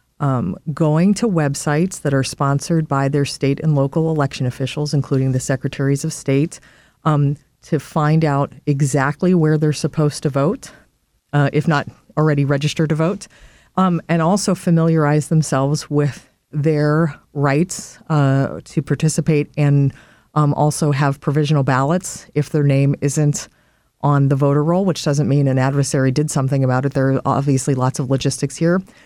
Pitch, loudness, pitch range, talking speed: 145 Hz, -18 LUFS, 140-160 Hz, 160 wpm